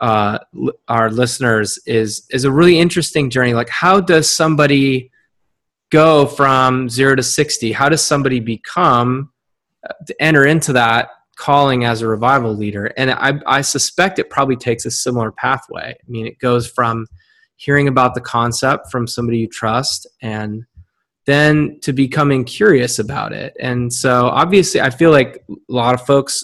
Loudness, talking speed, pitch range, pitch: -14 LUFS, 165 wpm, 115-140 Hz, 130 Hz